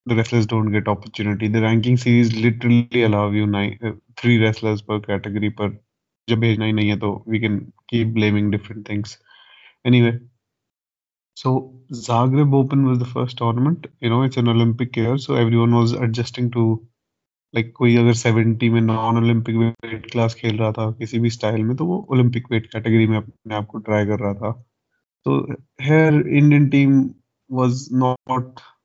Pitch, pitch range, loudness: 115 Hz, 110-125 Hz, -19 LUFS